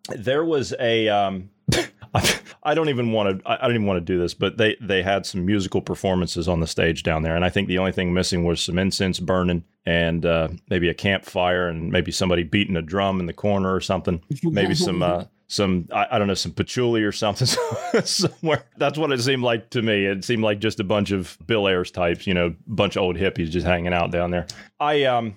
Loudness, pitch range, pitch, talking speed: -22 LUFS, 90-105 Hz, 95 Hz, 235 wpm